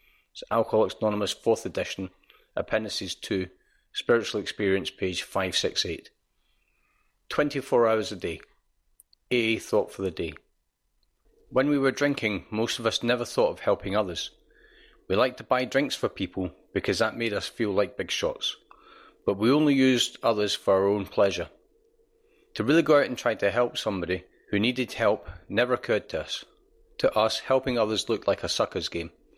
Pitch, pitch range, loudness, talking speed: 125 Hz, 105-150 Hz, -27 LUFS, 165 wpm